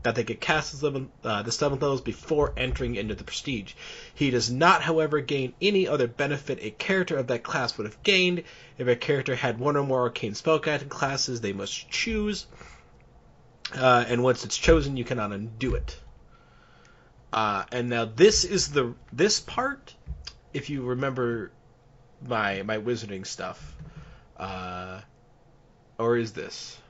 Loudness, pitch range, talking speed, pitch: -26 LUFS, 115-145 Hz, 155 wpm, 125 Hz